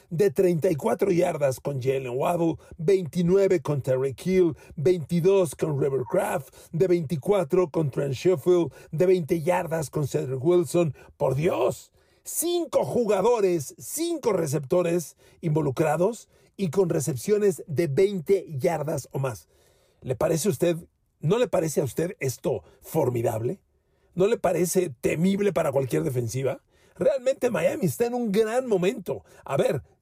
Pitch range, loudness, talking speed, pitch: 150-190 Hz, -25 LUFS, 130 wpm, 175 Hz